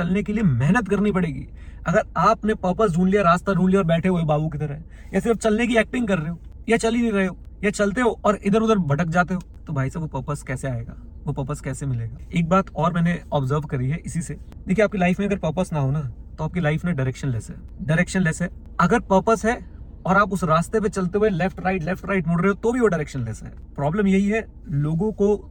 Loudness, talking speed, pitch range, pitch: -22 LUFS, 120 wpm, 150-205 Hz, 180 Hz